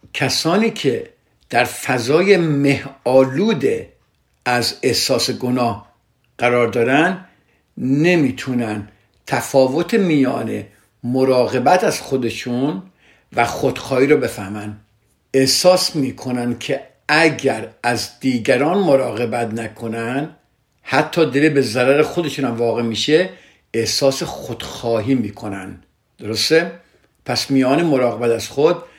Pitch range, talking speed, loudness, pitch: 115-150 Hz, 95 wpm, -17 LUFS, 130 Hz